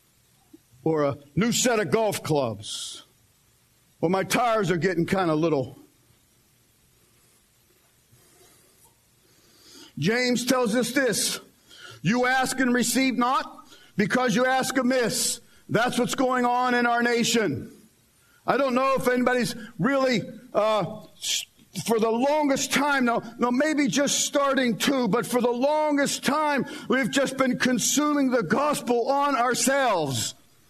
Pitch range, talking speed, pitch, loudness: 220-270 Hz, 125 wpm, 245 Hz, -24 LUFS